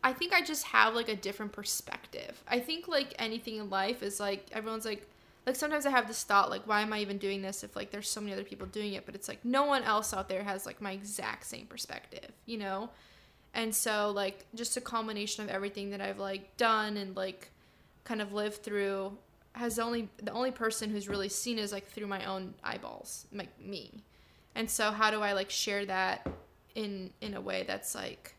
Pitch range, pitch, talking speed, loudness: 195-230 Hz, 210 Hz, 220 wpm, -34 LUFS